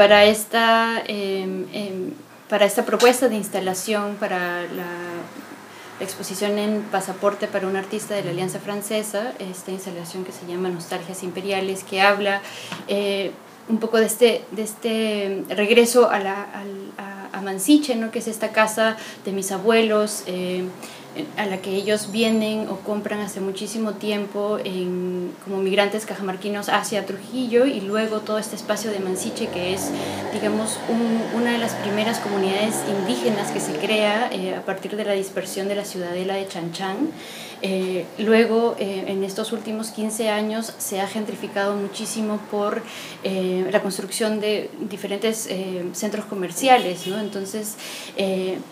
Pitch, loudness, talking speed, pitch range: 205 Hz, -23 LUFS, 150 wpm, 190-215 Hz